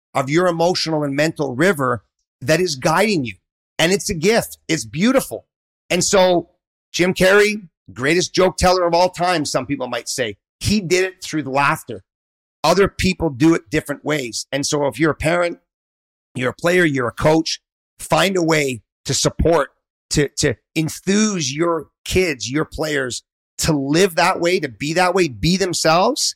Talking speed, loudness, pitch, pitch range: 175 wpm, -18 LUFS, 160 Hz, 140-180 Hz